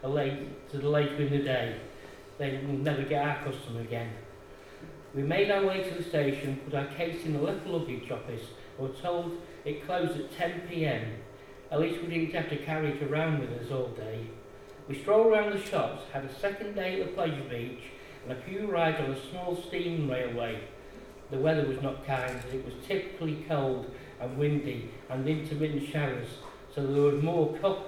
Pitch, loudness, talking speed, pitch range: 140 Hz, -32 LUFS, 200 wpm, 130-165 Hz